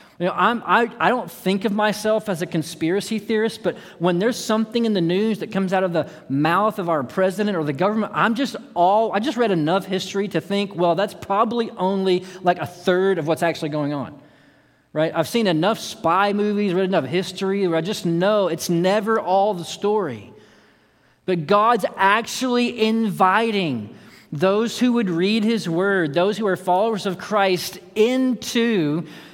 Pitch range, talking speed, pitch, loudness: 175-215 Hz, 180 wpm, 195 Hz, -21 LUFS